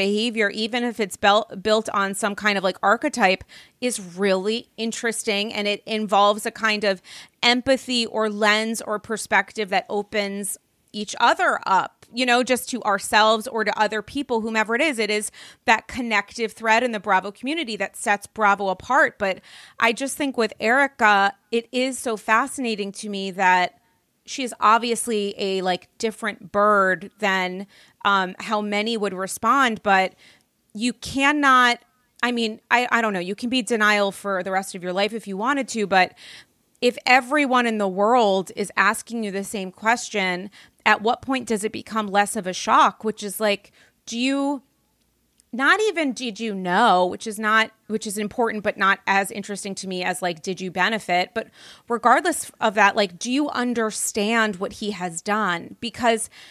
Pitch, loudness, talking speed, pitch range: 215 Hz, -22 LUFS, 175 wpm, 200-235 Hz